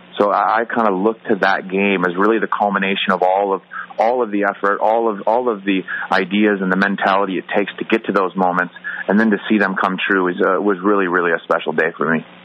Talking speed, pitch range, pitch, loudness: 250 wpm, 95-105 Hz, 100 Hz, -17 LUFS